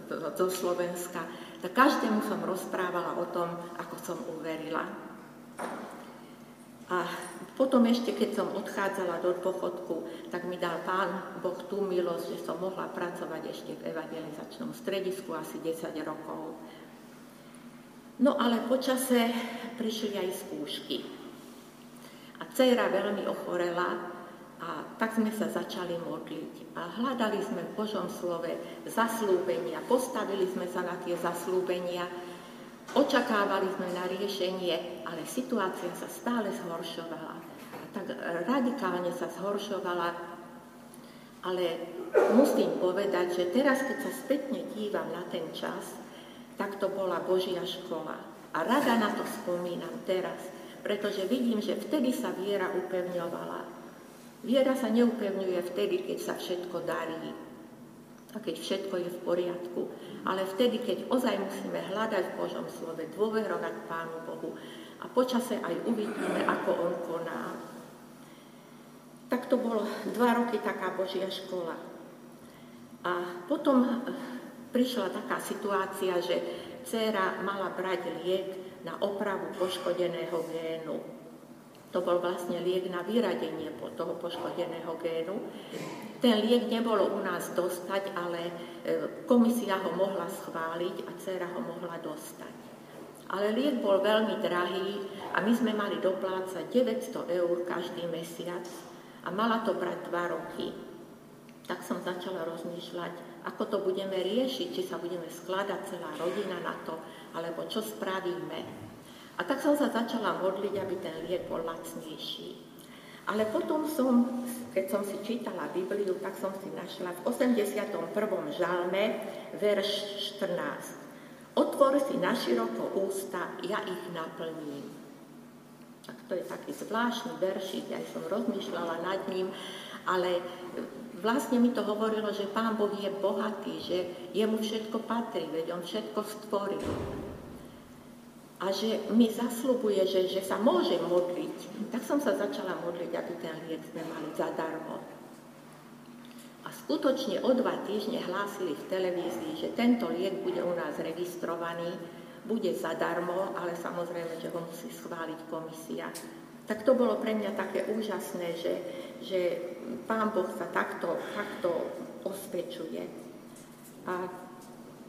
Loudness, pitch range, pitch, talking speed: -32 LUFS, 180-220 Hz, 190 Hz, 130 wpm